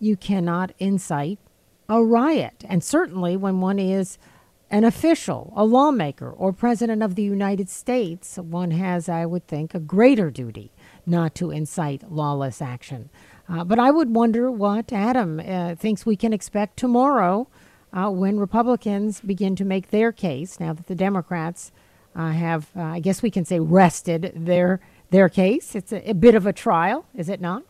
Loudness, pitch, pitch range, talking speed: -21 LUFS, 190 Hz, 170-215 Hz, 175 wpm